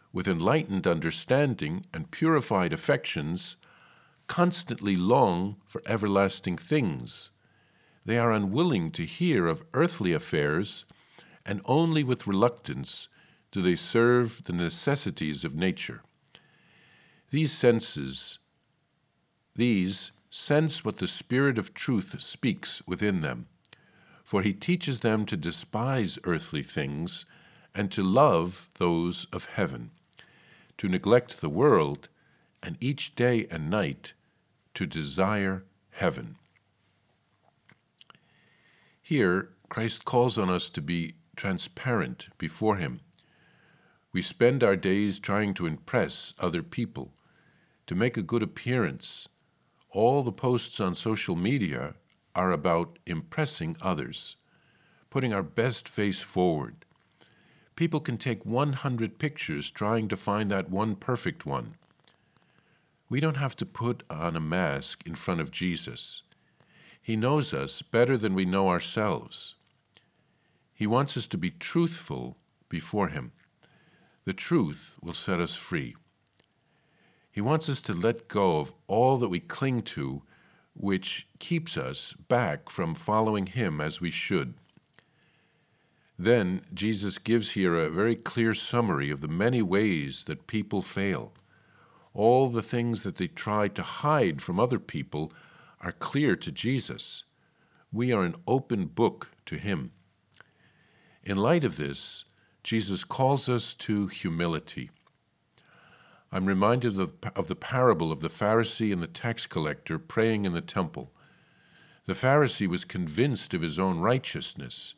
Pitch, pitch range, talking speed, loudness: 110 Hz, 95-135 Hz, 130 wpm, -29 LUFS